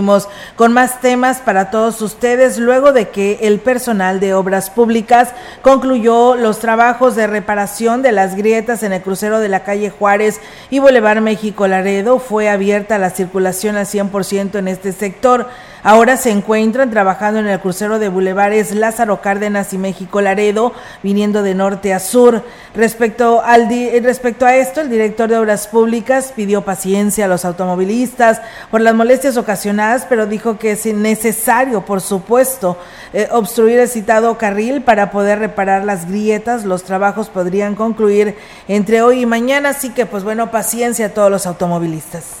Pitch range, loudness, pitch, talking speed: 200-235 Hz, -13 LUFS, 215 Hz, 165 wpm